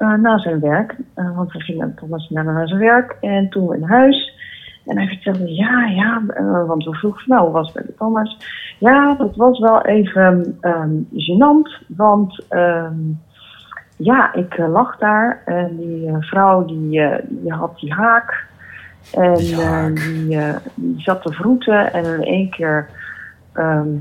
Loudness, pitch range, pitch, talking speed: -16 LUFS, 165-220 Hz, 180 Hz, 160 wpm